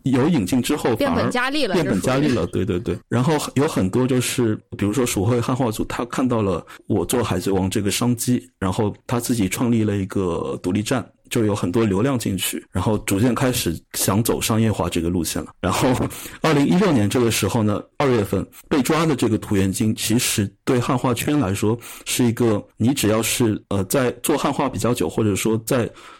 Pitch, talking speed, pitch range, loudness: 110 Hz, 305 characters per minute, 100-125 Hz, -21 LUFS